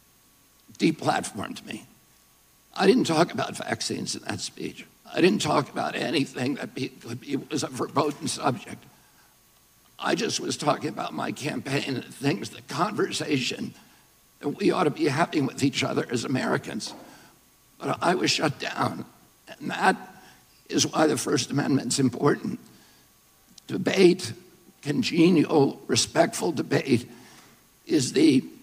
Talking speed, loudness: 140 wpm, -25 LUFS